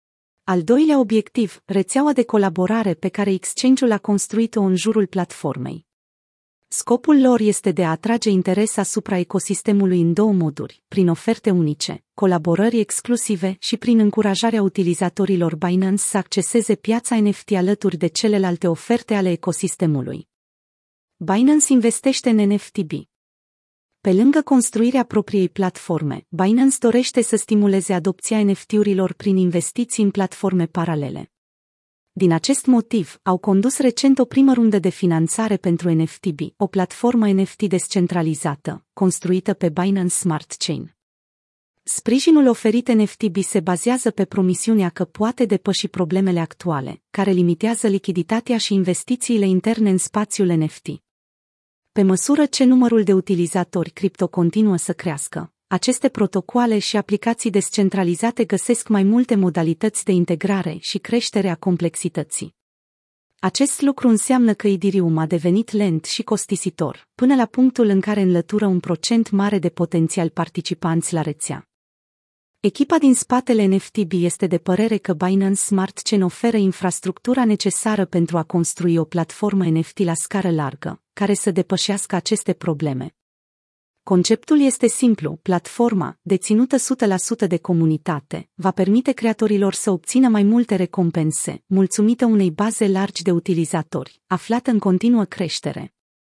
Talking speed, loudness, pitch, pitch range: 130 wpm, -19 LUFS, 195 Hz, 175-220 Hz